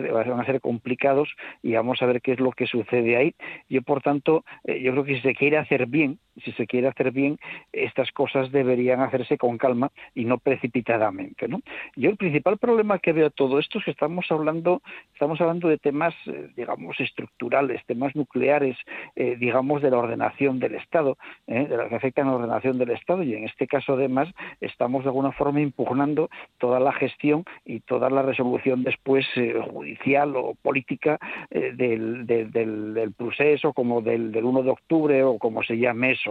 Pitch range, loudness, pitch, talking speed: 125-145 Hz, -24 LUFS, 135 Hz, 190 wpm